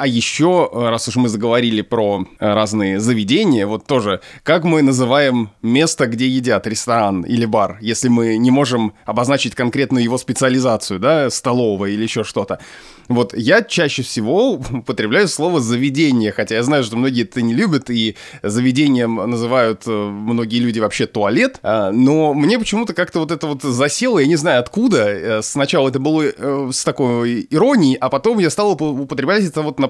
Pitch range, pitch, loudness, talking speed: 115-145 Hz, 130 Hz, -16 LUFS, 165 wpm